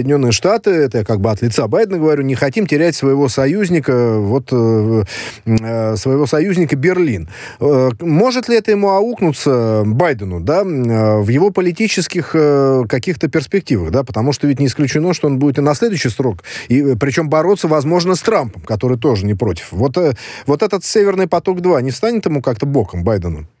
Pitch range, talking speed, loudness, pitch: 120-175 Hz, 180 wpm, -15 LUFS, 140 Hz